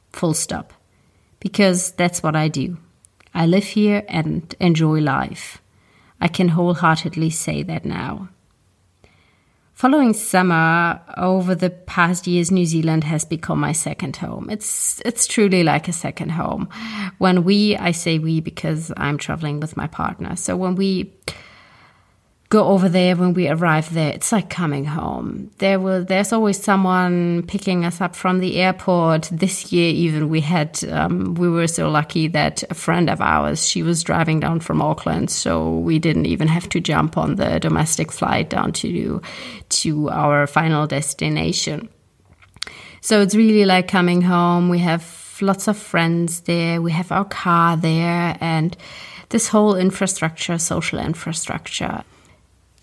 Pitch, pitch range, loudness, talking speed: 175 Hz, 160-185 Hz, -19 LUFS, 160 wpm